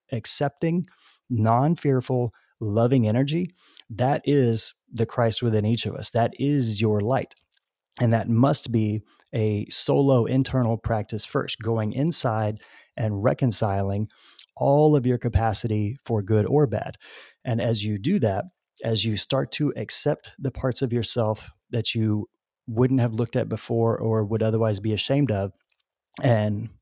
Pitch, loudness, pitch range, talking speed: 115 Hz, -24 LUFS, 110-130 Hz, 150 wpm